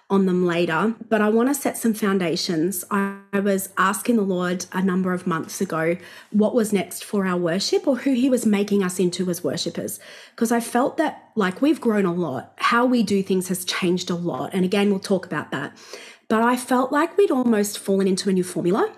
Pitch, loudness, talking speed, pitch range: 200 Hz, -22 LUFS, 220 wpm, 180-235 Hz